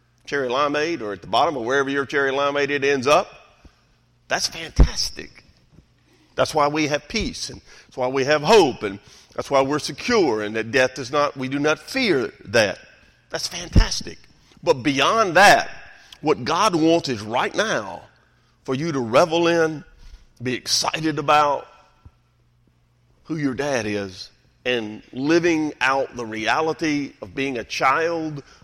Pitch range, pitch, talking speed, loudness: 120-155 Hz, 140 Hz, 155 wpm, -21 LUFS